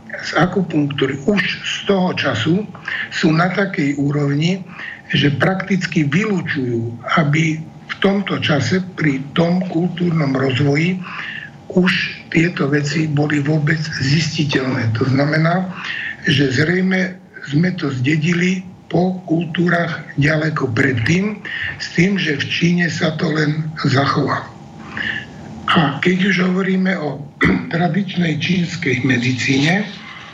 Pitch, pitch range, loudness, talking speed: 165 Hz, 145-180 Hz, -17 LUFS, 110 wpm